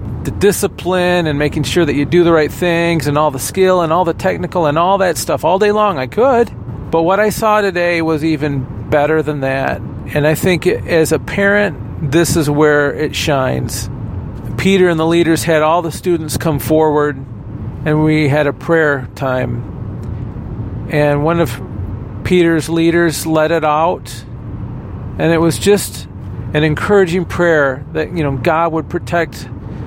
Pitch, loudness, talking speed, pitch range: 155 Hz, -14 LUFS, 175 wpm, 130-170 Hz